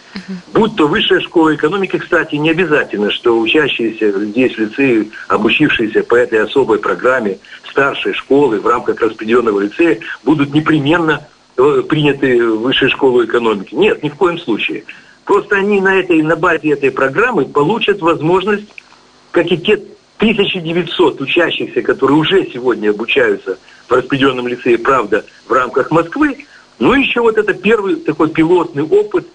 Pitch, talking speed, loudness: 200 Hz, 145 wpm, -13 LUFS